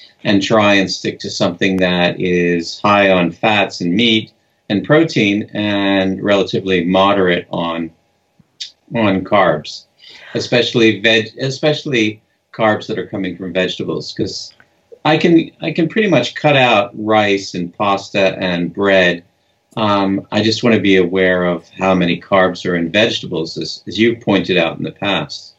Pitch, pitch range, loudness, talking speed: 100 Hz, 90-115 Hz, -15 LUFS, 155 wpm